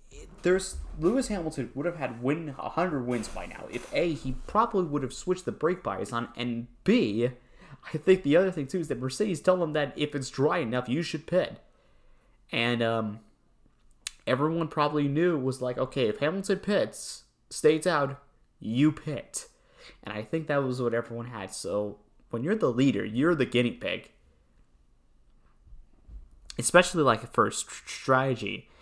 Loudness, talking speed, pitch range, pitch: -28 LUFS, 170 wpm, 120-170 Hz, 140 Hz